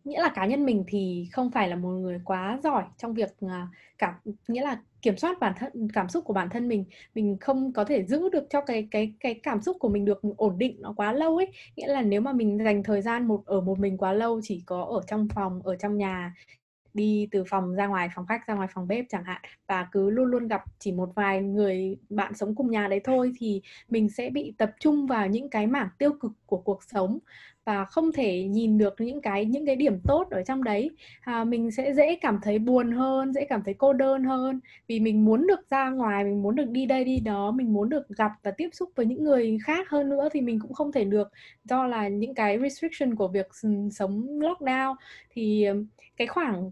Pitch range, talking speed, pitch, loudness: 200-260 Hz, 240 wpm, 220 Hz, -27 LUFS